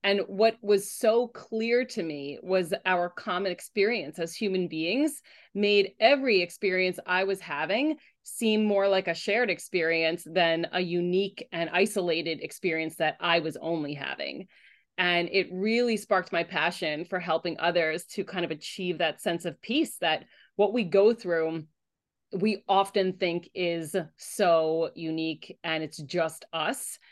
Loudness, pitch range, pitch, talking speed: -27 LUFS, 165-205 Hz, 185 Hz, 155 wpm